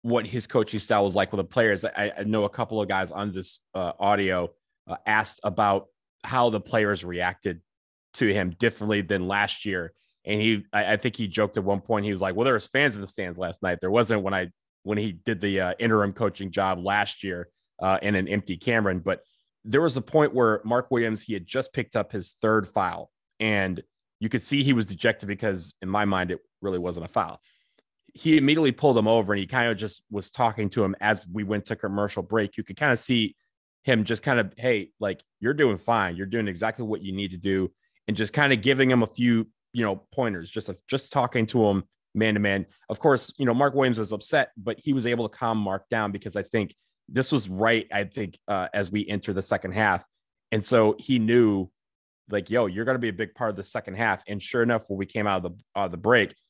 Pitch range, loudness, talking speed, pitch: 100-115 Hz, -26 LUFS, 240 wpm, 105 Hz